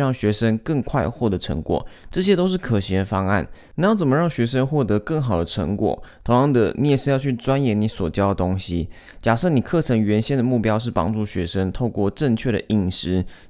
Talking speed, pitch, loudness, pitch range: 310 characters per minute, 110 Hz, -21 LUFS, 95-130 Hz